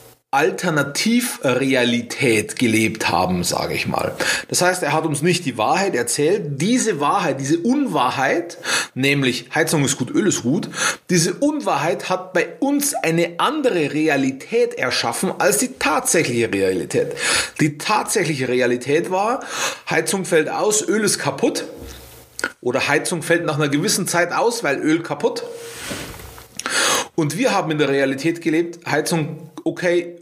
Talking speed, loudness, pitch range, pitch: 135 wpm, -19 LUFS, 135-190 Hz, 160 Hz